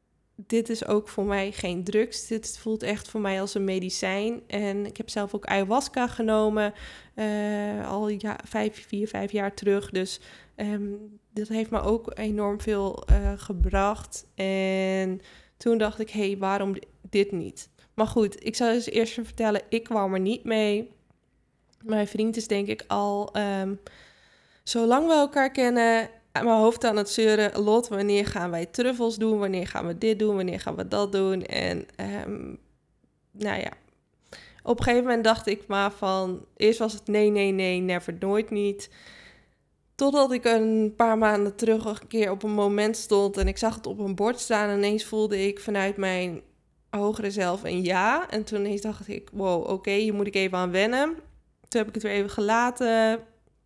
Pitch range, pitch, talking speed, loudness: 200-225 Hz, 210 Hz, 185 wpm, -26 LUFS